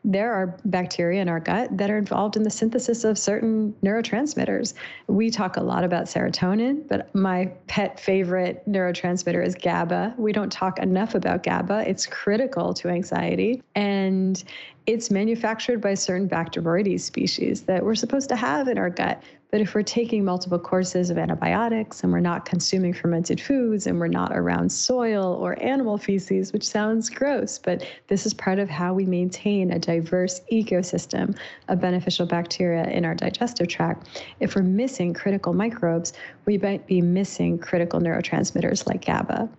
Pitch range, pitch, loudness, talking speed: 180-215 Hz, 195 Hz, -24 LUFS, 165 wpm